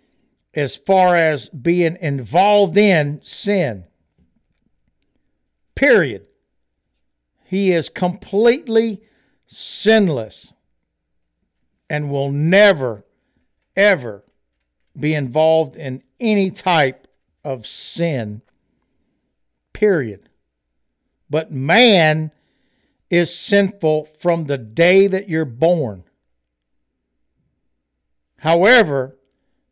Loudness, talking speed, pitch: -16 LUFS, 70 wpm, 150 Hz